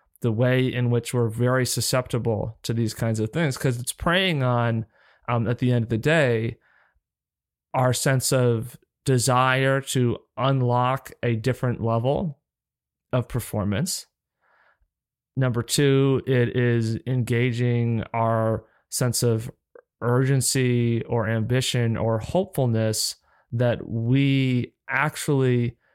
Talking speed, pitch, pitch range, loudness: 115 wpm, 125 Hz, 115-130 Hz, -23 LUFS